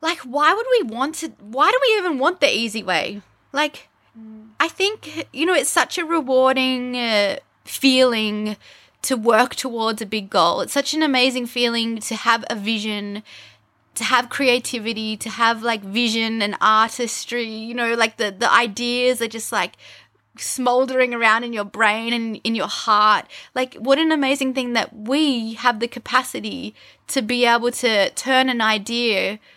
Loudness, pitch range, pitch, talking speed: -19 LUFS, 220-265 Hz, 240 Hz, 170 wpm